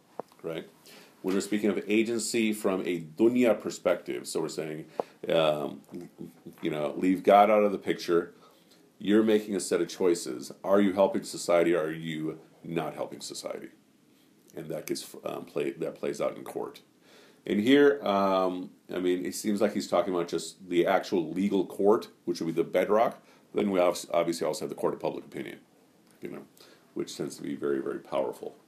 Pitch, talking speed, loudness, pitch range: 95 Hz, 185 wpm, -28 LUFS, 85-105 Hz